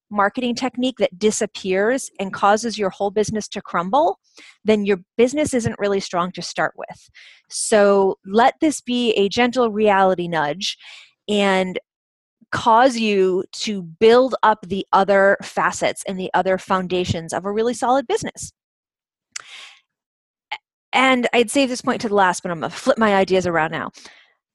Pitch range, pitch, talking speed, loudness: 190-240 Hz, 205 Hz, 155 wpm, -19 LUFS